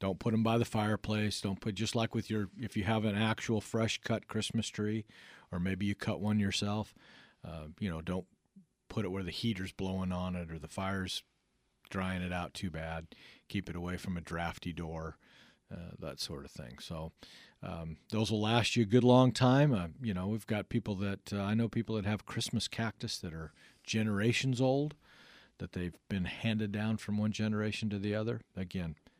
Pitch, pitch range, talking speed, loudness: 105 Hz, 90-110 Hz, 205 wpm, -35 LUFS